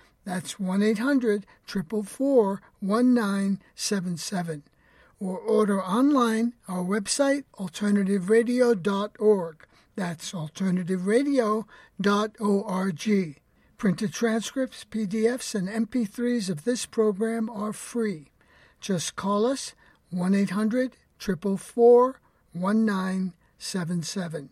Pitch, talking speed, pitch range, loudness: 205 Hz, 70 wpm, 190-230 Hz, -26 LUFS